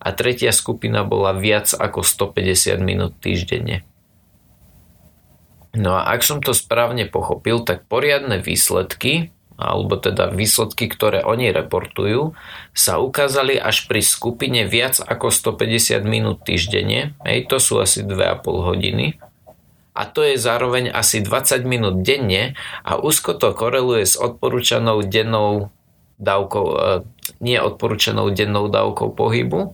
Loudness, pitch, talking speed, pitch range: -18 LUFS, 110 Hz, 125 wpm, 95-120 Hz